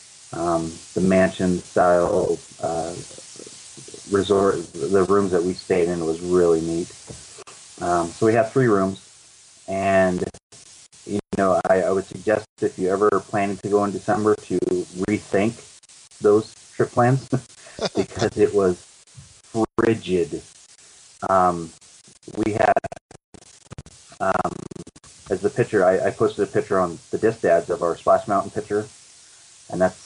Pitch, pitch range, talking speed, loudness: 95 Hz, 90-105 Hz, 135 wpm, -22 LUFS